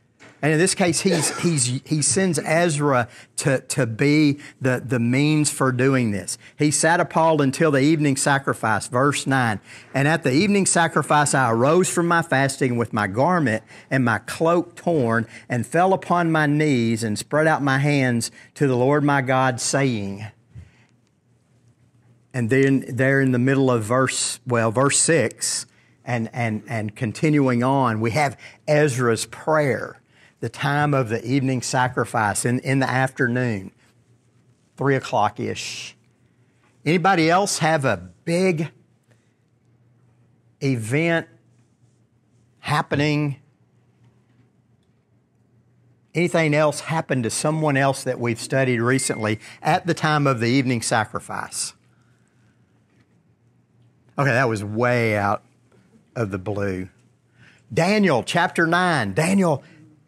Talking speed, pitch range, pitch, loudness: 130 wpm, 120-150 Hz, 130 Hz, -21 LUFS